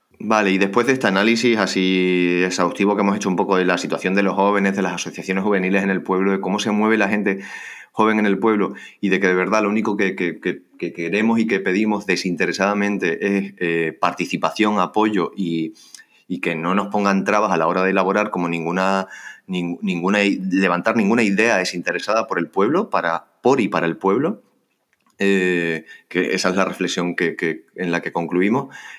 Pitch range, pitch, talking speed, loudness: 90-105 Hz, 95 Hz, 200 wpm, -19 LUFS